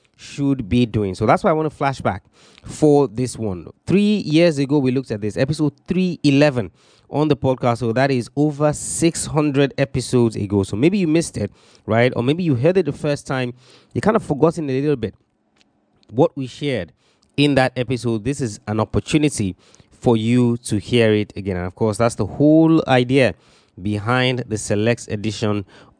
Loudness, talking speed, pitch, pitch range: -19 LUFS, 185 wpm, 125 Hz, 110-145 Hz